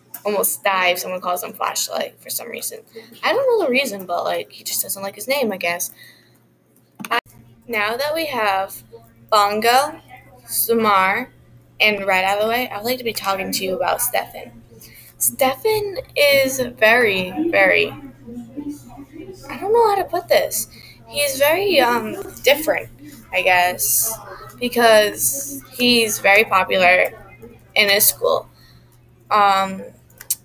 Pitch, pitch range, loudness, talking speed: 215 Hz, 185-275 Hz, -18 LUFS, 140 wpm